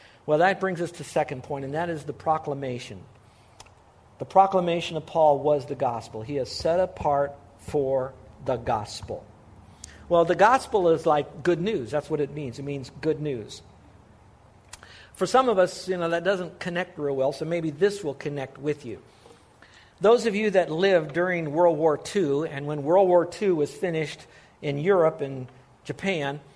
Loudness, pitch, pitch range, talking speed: -25 LUFS, 150 Hz, 135-175 Hz, 180 wpm